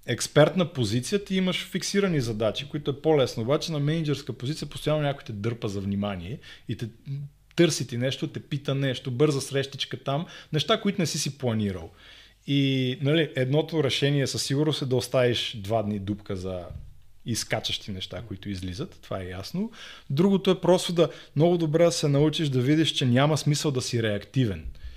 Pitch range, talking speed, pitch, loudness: 115-155 Hz, 175 wpm, 140 Hz, -26 LUFS